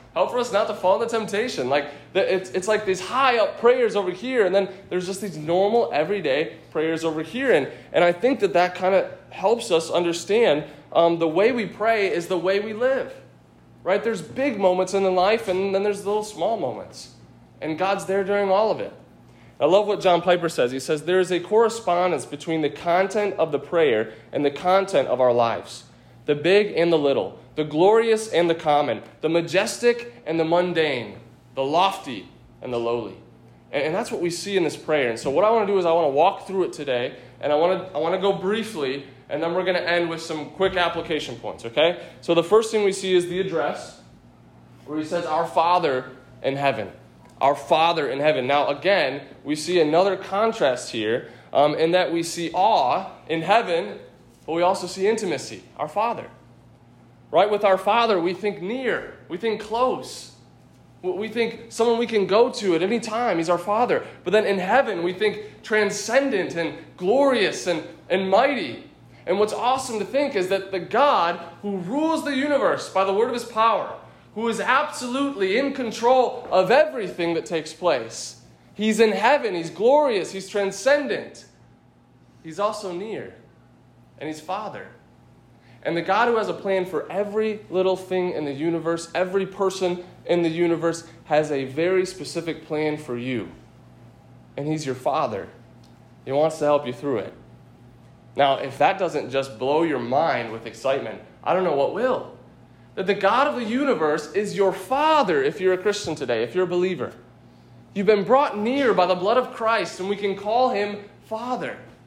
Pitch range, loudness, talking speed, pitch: 160-215 Hz, -22 LUFS, 195 wpm, 185 Hz